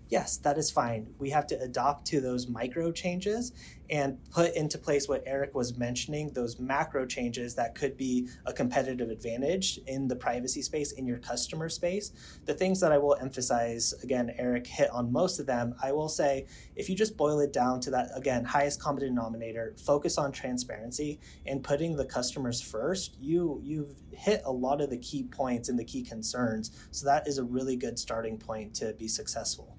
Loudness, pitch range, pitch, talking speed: -31 LUFS, 120-150 Hz, 135 Hz, 195 wpm